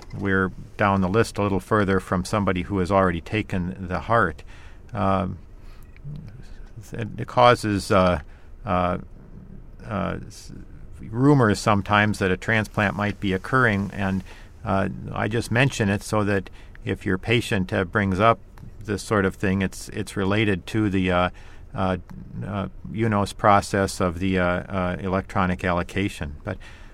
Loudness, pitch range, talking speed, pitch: -23 LUFS, 95-105 Hz, 145 wpm, 95 Hz